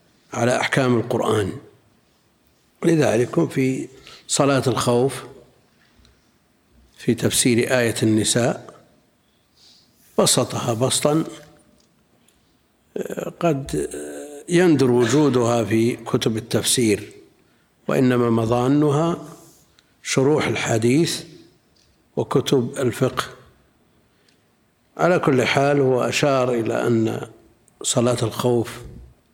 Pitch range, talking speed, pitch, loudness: 115-140 Hz, 70 wpm, 125 Hz, -20 LUFS